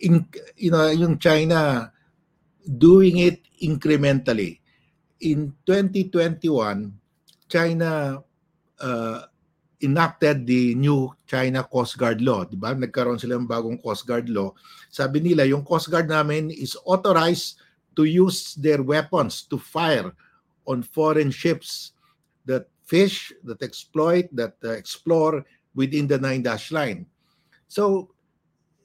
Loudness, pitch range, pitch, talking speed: -22 LUFS, 130-170 Hz, 155 Hz, 120 wpm